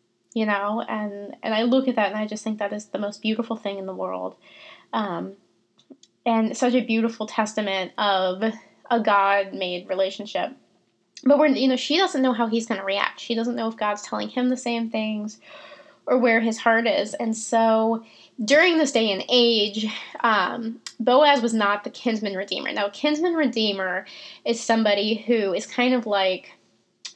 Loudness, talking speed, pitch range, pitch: -23 LUFS, 185 wpm, 205-240 Hz, 225 Hz